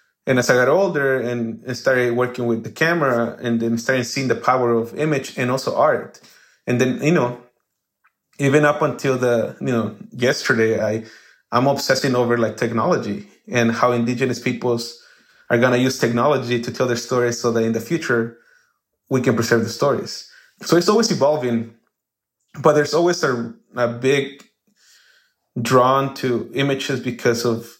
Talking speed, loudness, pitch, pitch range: 165 wpm, -19 LUFS, 125 Hz, 120-135 Hz